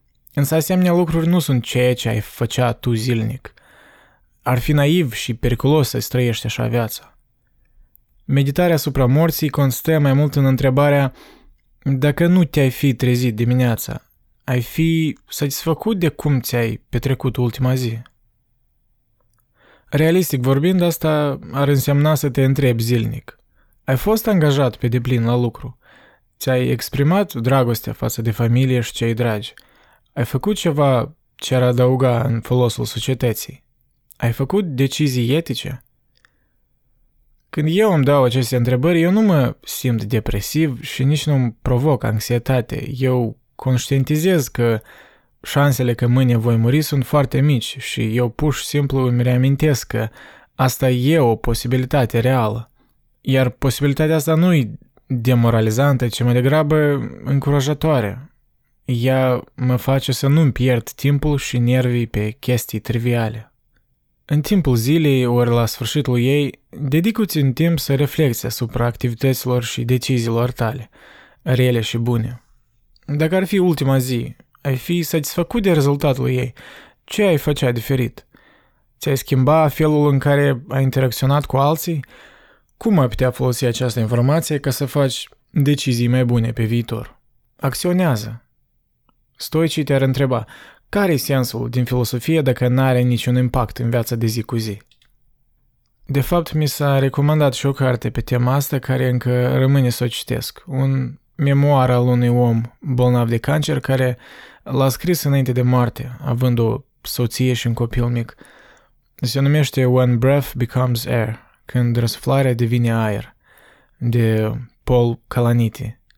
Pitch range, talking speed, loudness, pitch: 120-145 Hz, 140 wpm, -18 LUFS, 130 Hz